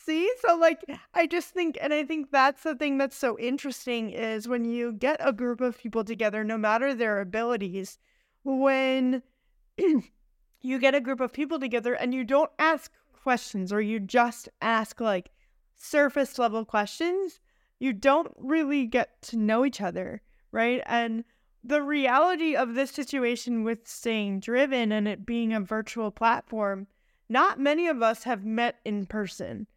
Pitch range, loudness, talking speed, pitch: 225-280 Hz, -27 LUFS, 165 wpm, 245 Hz